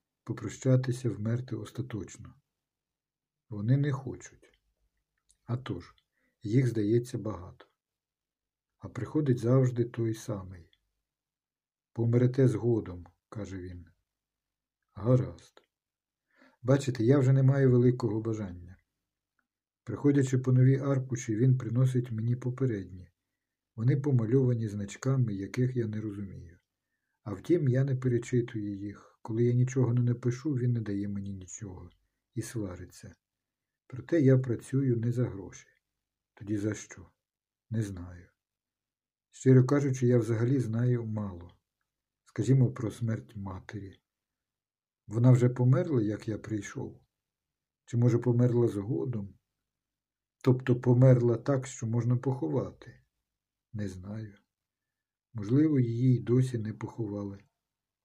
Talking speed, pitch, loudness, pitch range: 110 wpm, 120 Hz, -29 LUFS, 105-130 Hz